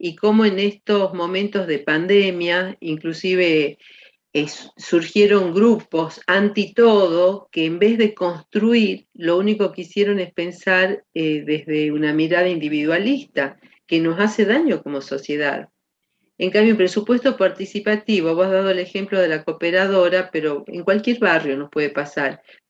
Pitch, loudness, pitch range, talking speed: 185 Hz, -19 LUFS, 160-205 Hz, 145 wpm